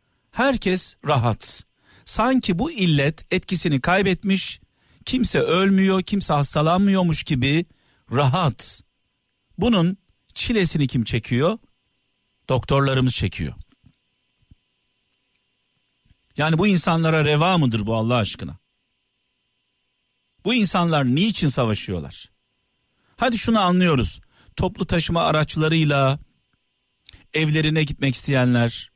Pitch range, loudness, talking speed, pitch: 120-180 Hz, -20 LUFS, 85 wpm, 145 Hz